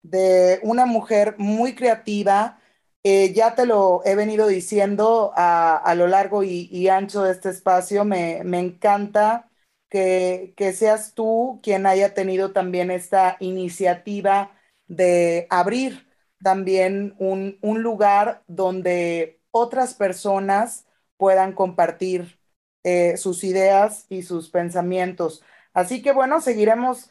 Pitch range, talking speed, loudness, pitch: 185-210 Hz, 125 wpm, -20 LUFS, 195 Hz